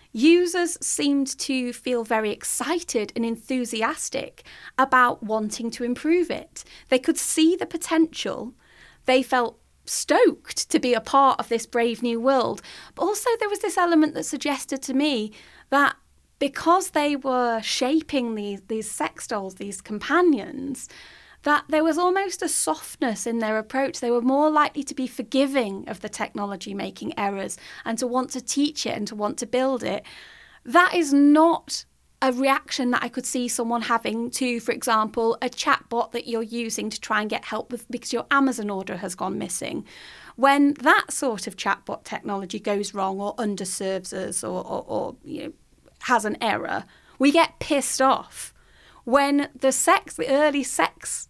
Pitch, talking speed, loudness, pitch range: 255 Hz, 170 wpm, -23 LUFS, 230-290 Hz